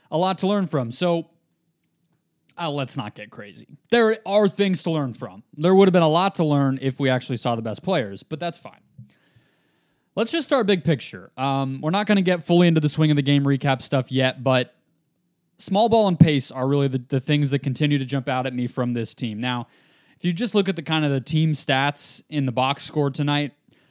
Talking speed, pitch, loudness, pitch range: 235 wpm, 150 Hz, -22 LUFS, 135-175 Hz